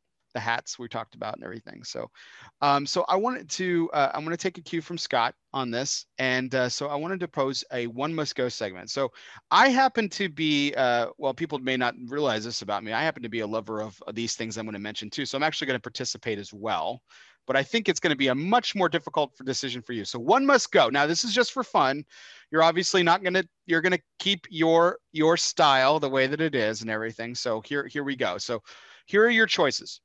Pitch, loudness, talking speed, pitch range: 140 Hz, -26 LUFS, 250 wpm, 120-170 Hz